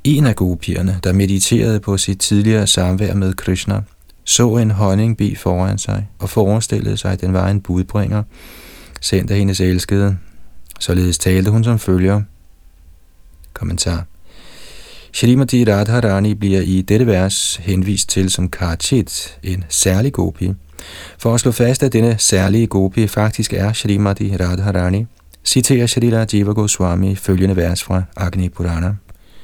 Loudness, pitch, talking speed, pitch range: -16 LUFS, 95 Hz, 140 wpm, 90-105 Hz